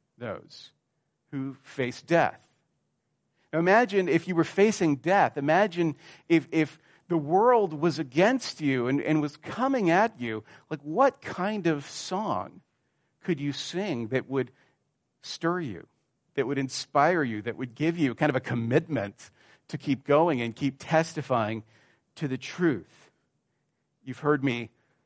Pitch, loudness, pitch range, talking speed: 150 Hz, -27 LUFS, 130-170 Hz, 145 wpm